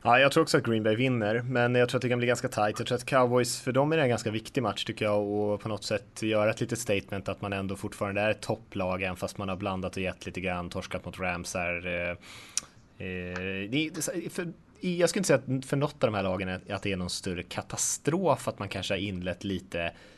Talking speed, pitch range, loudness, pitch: 230 wpm, 95-125 Hz, -29 LUFS, 105 Hz